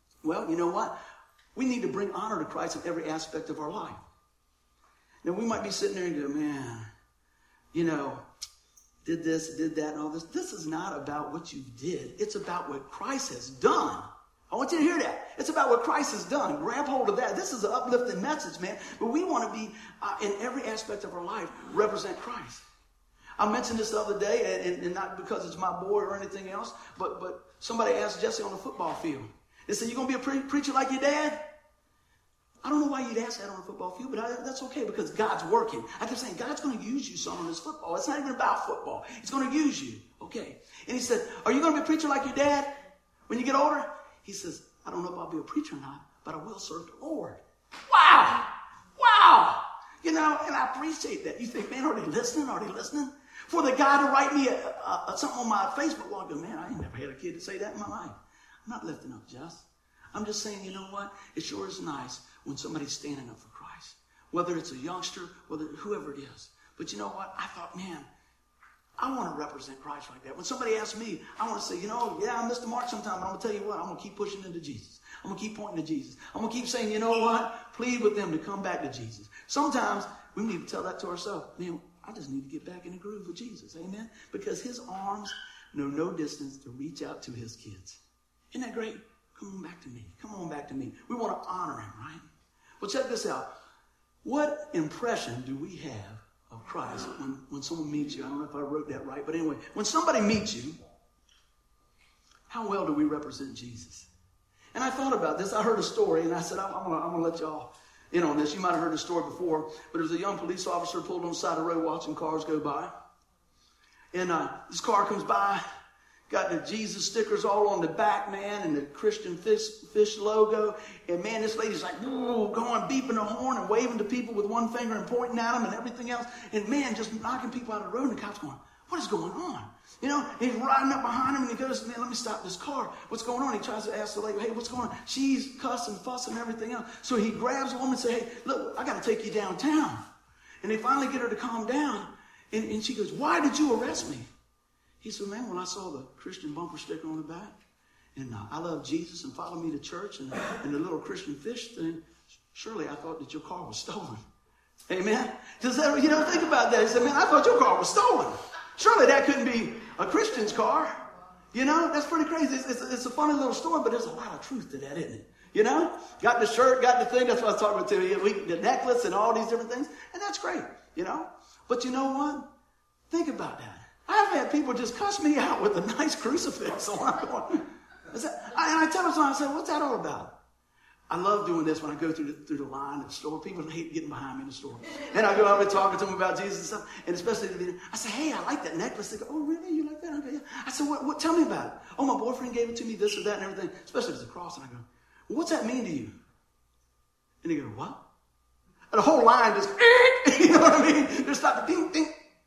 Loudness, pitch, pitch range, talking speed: -29 LUFS, 220 Hz, 165-275 Hz, 250 wpm